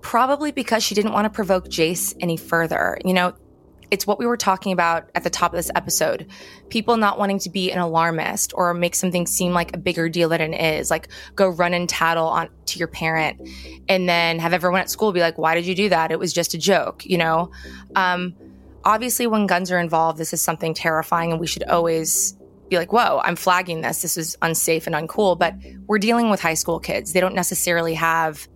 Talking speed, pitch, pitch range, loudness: 225 wpm, 175 Hz, 165-185 Hz, -20 LUFS